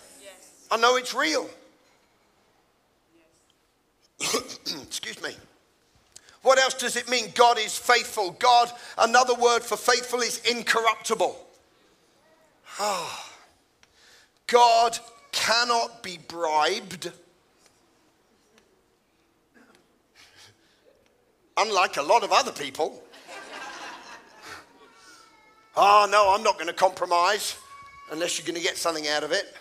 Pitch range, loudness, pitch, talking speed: 185-245 Hz, -23 LUFS, 235 Hz, 100 wpm